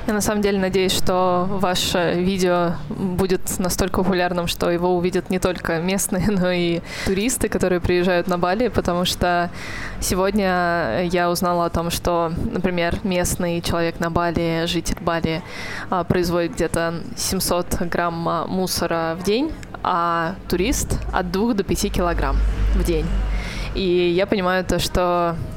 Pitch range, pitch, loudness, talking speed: 170-190 Hz, 180 Hz, -21 LUFS, 140 wpm